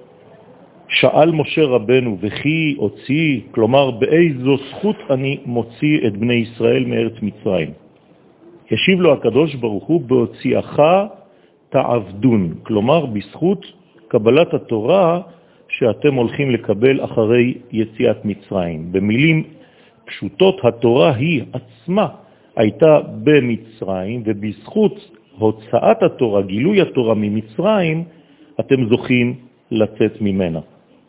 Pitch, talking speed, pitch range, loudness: 125 Hz, 90 wpm, 110-150 Hz, -17 LUFS